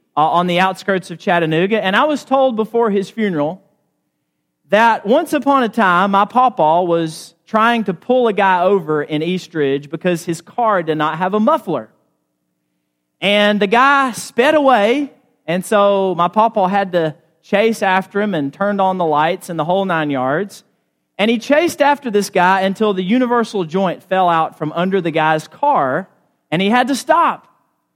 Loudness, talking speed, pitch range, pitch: -15 LUFS, 180 wpm, 165-220 Hz, 190 Hz